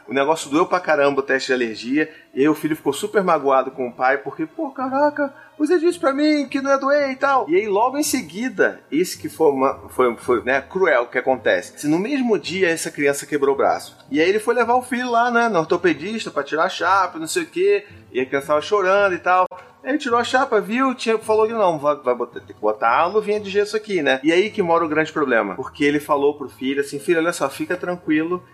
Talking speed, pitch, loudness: 255 wpm, 205 Hz, -20 LUFS